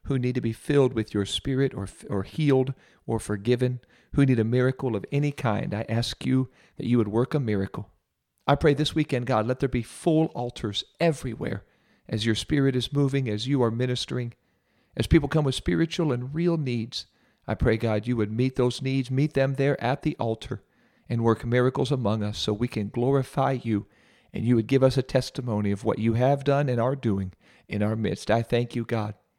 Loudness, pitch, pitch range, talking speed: -26 LUFS, 125 Hz, 110-135 Hz, 210 wpm